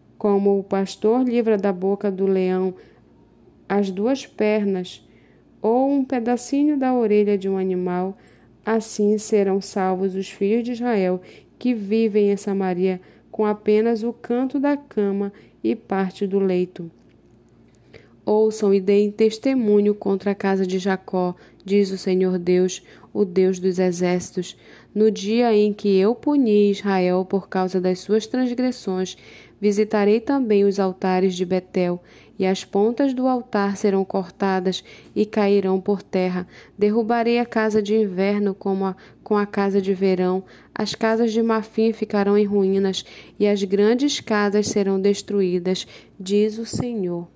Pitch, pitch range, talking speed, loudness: 200 Hz, 190-215 Hz, 145 wpm, -21 LUFS